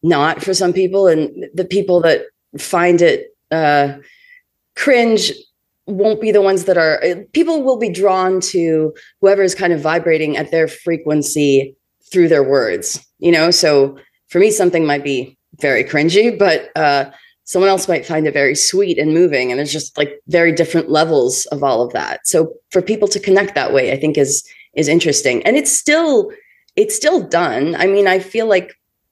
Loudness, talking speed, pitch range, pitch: -14 LUFS, 185 wpm, 155-205 Hz, 175 Hz